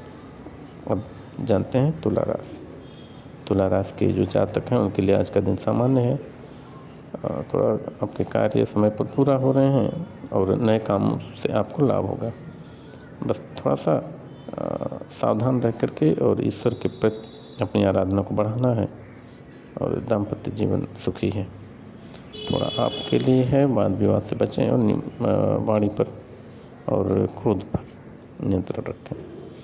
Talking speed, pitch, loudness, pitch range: 140 wpm, 115 Hz, -23 LUFS, 105-130 Hz